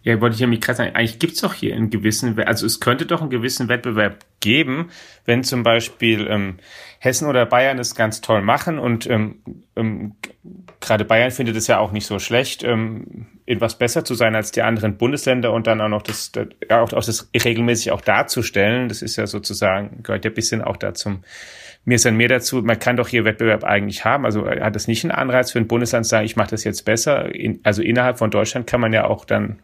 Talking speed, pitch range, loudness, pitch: 235 wpm, 110-125 Hz, -19 LUFS, 115 Hz